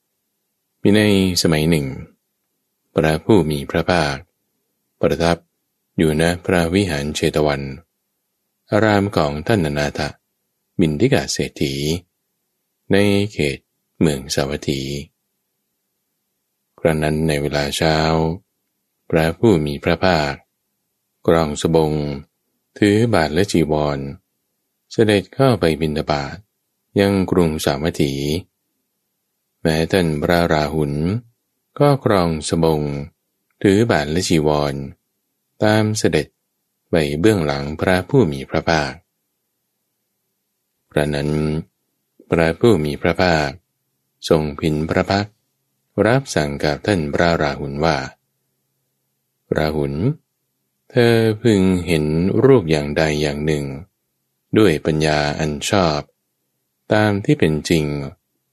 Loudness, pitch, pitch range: -18 LUFS, 80 Hz, 75-95 Hz